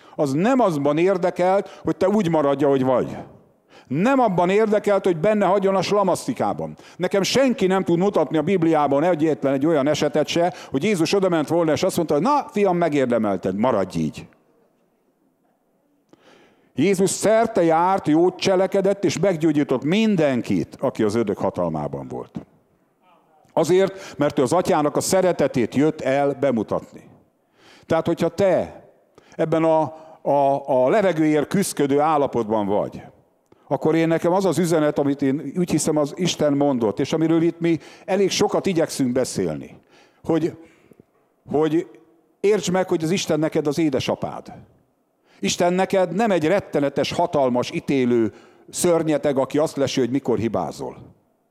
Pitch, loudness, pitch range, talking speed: 165 Hz, -20 LUFS, 145-185 Hz, 140 wpm